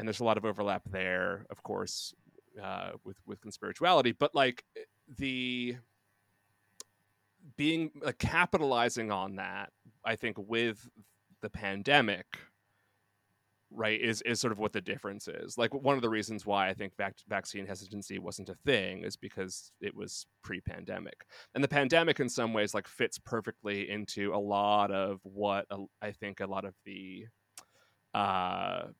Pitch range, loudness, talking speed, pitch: 100-115 Hz, -33 LUFS, 155 wpm, 100 Hz